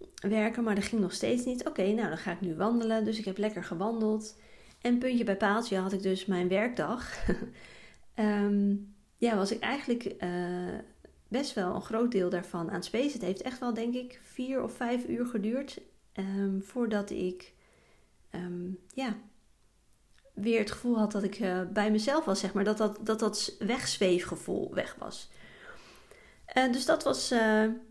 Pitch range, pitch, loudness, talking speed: 195-240 Hz, 215 Hz, -31 LUFS, 180 wpm